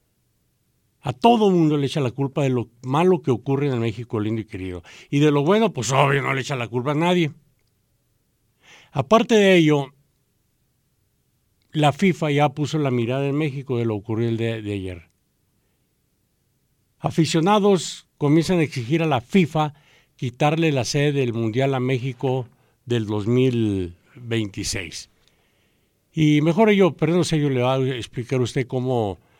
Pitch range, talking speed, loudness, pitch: 115-155 Hz, 160 wpm, -21 LUFS, 135 Hz